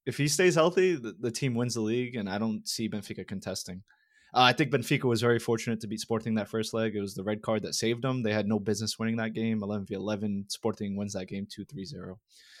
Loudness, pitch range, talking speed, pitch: -29 LUFS, 105-120 Hz, 250 wpm, 110 Hz